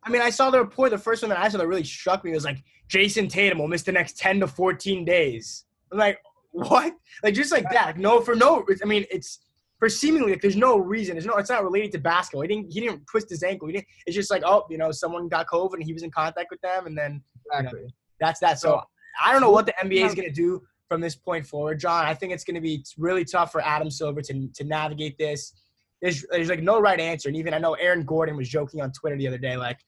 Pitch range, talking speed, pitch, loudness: 155-200 Hz, 275 wpm, 175 Hz, -23 LUFS